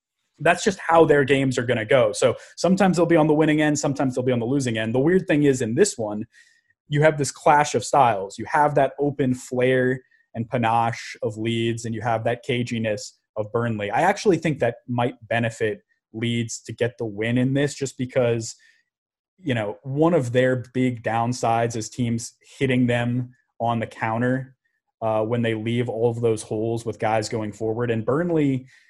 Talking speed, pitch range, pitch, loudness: 200 wpm, 115-140 Hz, 125 Hz, -22 LUFS